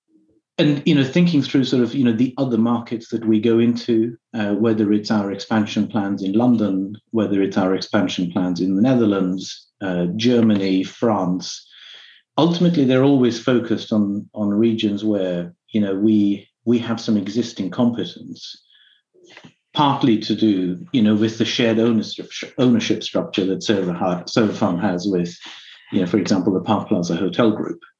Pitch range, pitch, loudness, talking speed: 100-120 Hz, 110 Hz, -19 LUFS, 160 wpm